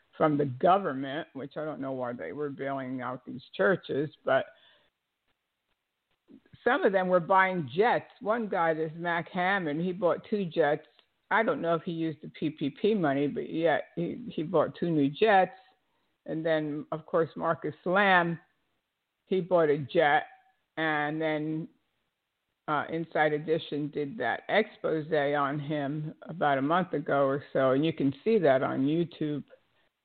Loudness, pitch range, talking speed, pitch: -29 LUFS, 145-180 Hz, 160 wpm, 160 Hz